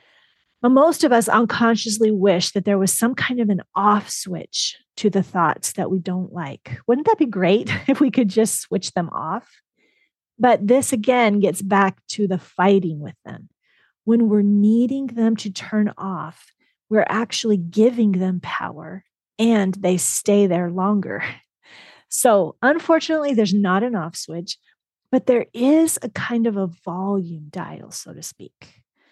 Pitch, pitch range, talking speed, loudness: 205 Hz, 185-235 Hz, 165 wpm, -19 LUFS